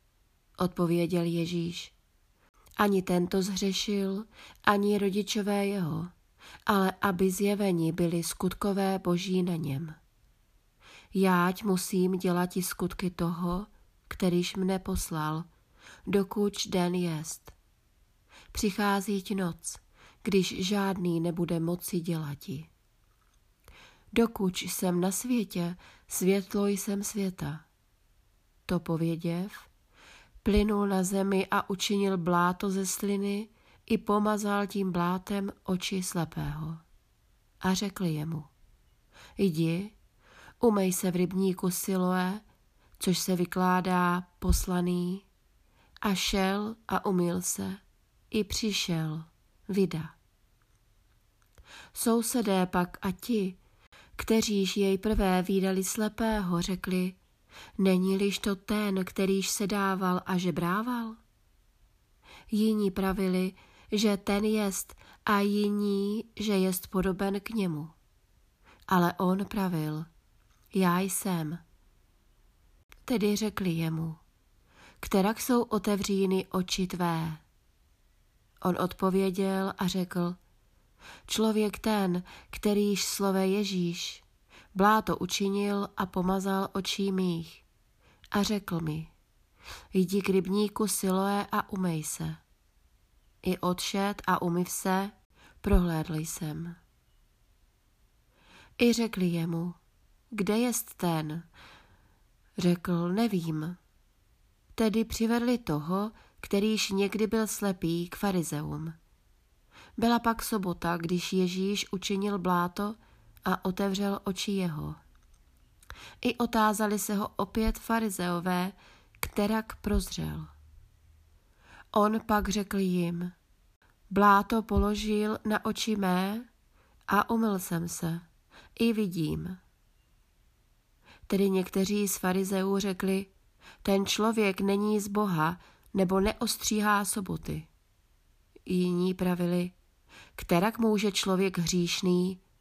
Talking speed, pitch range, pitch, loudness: 95 wpm, 175-205 Hz, 190 Hz, -29 LUFS